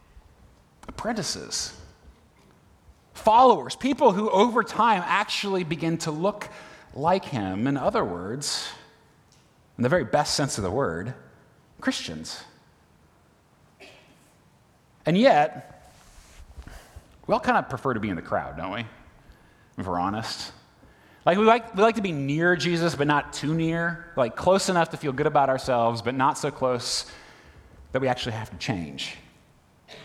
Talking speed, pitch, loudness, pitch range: 145 wpm, 160 Hz, -24 LUFS, 130-185 Hz